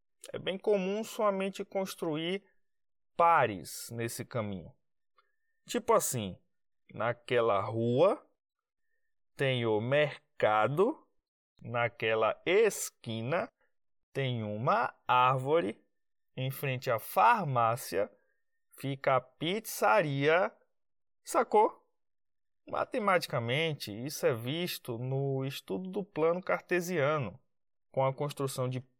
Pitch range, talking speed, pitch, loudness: 125-195 Hz, 85 wpm, 145 Hz, -31 LUFS